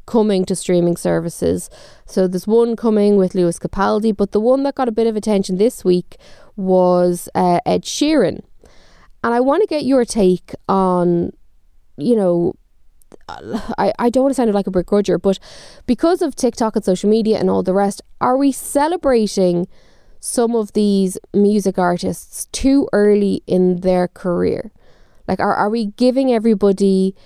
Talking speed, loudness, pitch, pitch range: 165 wpm, -17 LUFS, 205 Hz, 185-240 Hz